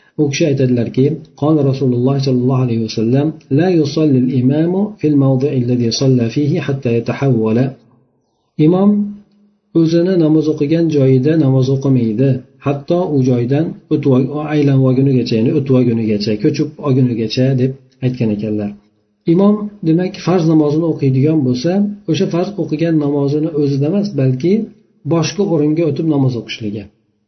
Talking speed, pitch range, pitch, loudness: 100 wpm, 125-160 Hz, 140 Hz, -14 LUFS